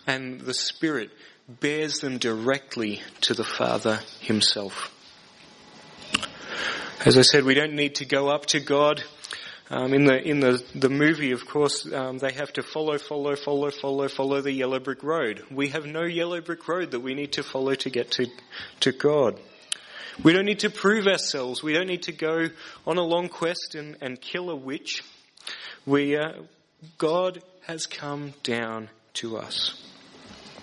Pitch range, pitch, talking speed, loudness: 130-160 Hz, 145 Hz, 170 wpm, -25 LUFS